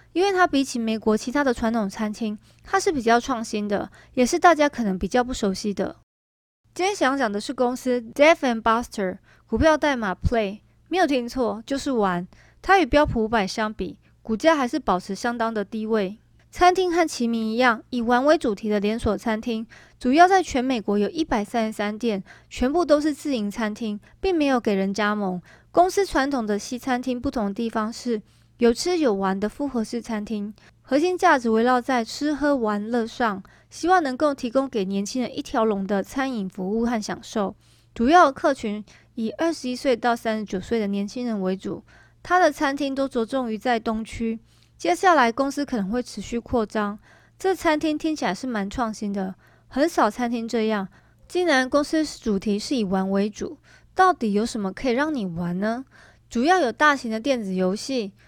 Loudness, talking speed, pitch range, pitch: -23 LUFS, 290 characters per minute, 210-280 Hz, 235 Hz